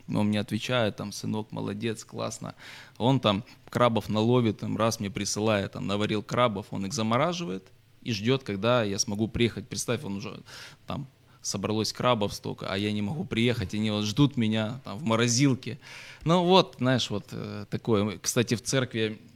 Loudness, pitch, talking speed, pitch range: -28 LUFS, 110 Hz, 175 wpm, 105-125 Hz